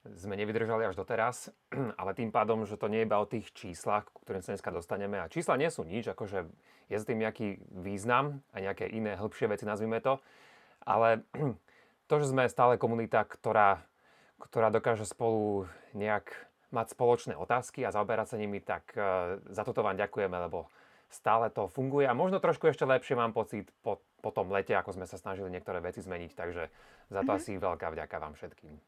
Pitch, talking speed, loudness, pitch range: 110 Hz, 185 wpm, -33 LUFS, 100-120 Hz